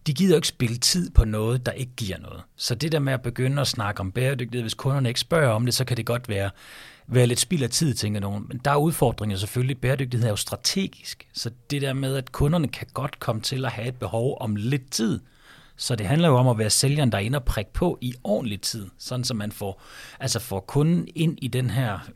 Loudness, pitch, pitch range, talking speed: -24 LUFS, 125 Hz, 110-135 Hz, 255 wpm